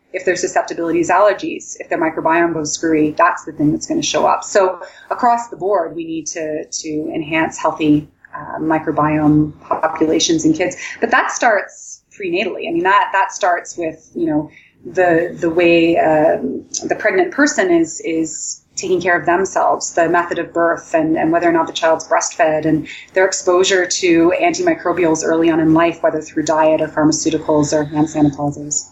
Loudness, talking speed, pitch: -16 LUFS, 180 wpm, 170 Hz